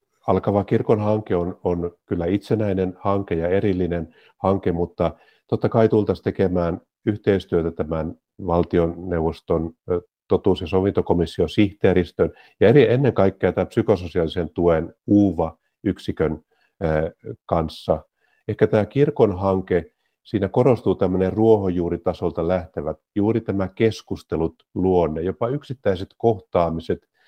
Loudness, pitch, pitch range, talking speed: -22 LUFS, 95 Hz, 85-105 Hz, 105 wpm